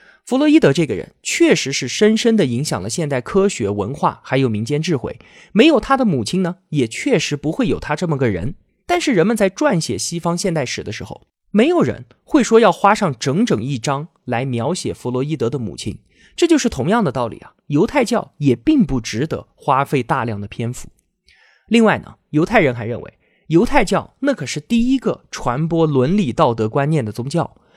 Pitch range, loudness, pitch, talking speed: 130-215 Hz, -18 LUFS, 160 Hz, 295 characters per minute